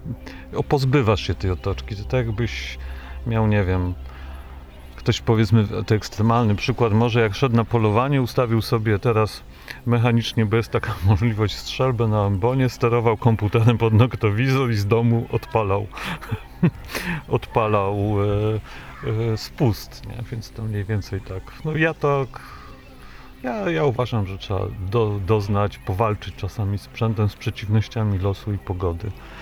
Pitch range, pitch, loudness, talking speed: 100-120 Hz, 110 Hz, -22 LUFS, 140 wpm